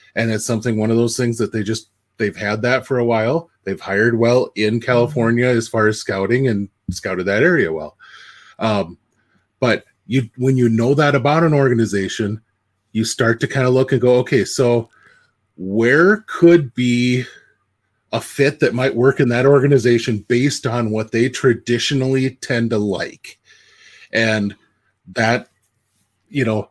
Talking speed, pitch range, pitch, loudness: 165 wpm, 110-130 Hz, 120 Hz, -17 LUFS